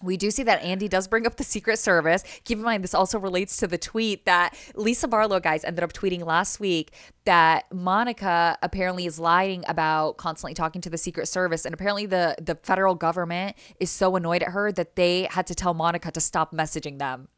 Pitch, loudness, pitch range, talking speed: 180 Hz, -24 LUFS, 170-195 Hz, 215 wpm